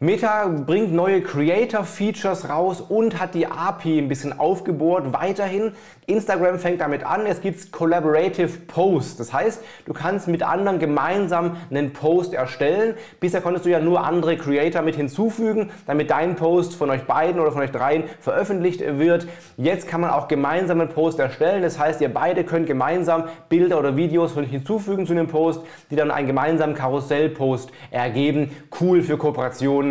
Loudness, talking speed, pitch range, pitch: -21 LUFS, 165 wpm, 150-185 Hz, 165 Hz